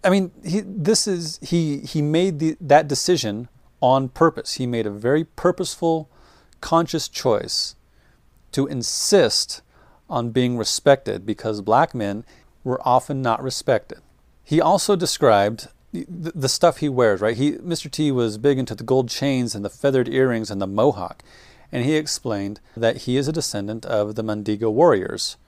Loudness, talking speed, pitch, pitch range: -21 LUFS, 165 wpm, 130 Hz, 115-160 Hz